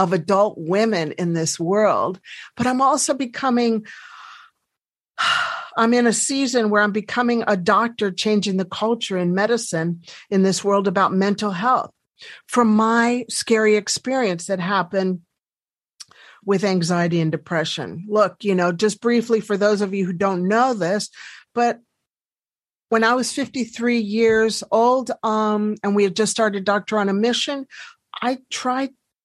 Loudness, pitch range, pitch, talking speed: -20 LUFS, 195-240 Hz, 215 Hz, 150 wpm